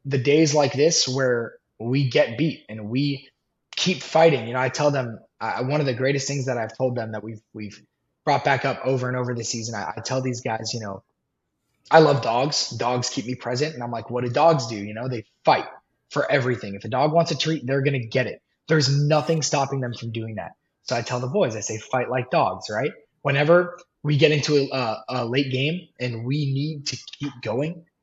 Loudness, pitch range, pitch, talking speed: -23 LUFS, 120-145 Hz, 130 Hz, 230 wpm